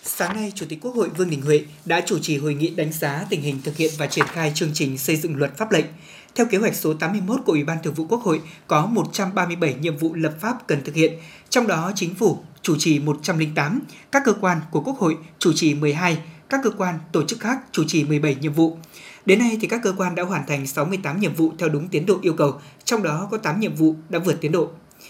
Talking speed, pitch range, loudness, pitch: 255 wpm, 155-190 Hz, -22 LUFS, 165 Hz